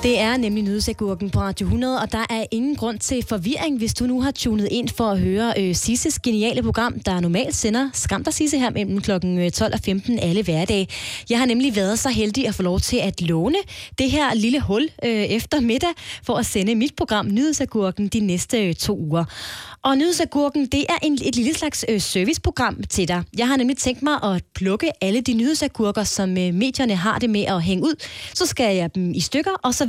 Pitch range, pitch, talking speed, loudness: 200-270 Hz, 230 Hz, 220 wpm, -21 LUFS